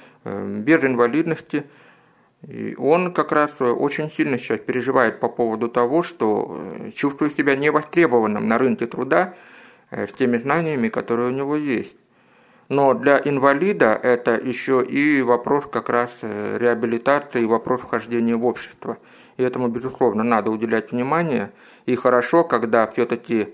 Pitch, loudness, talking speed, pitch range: 125 Hz, -20 LUFS, 135 wpm, 120-145 Hz